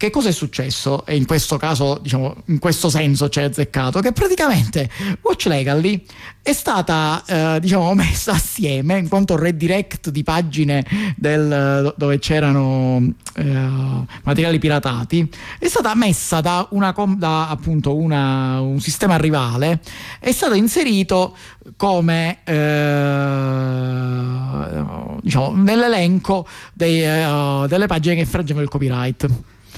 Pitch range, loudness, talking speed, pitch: 140-180 Hz, -18 LUFS, 125 wpm, 155 Hz